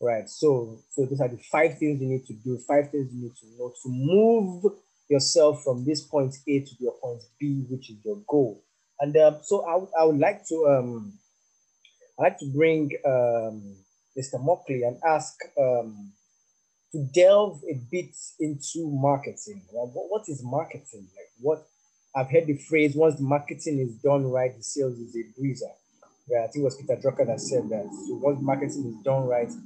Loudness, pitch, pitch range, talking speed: -25 LUFS, 140 Hz, 125-160 Hz, 195 wpm